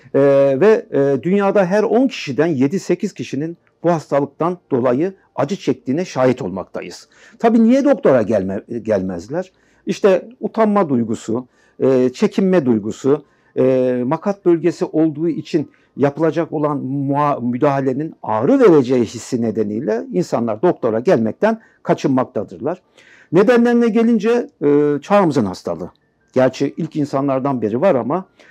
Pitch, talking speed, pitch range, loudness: 150 Hz, 100 wpm, 130-195 Hz, -17 LUFS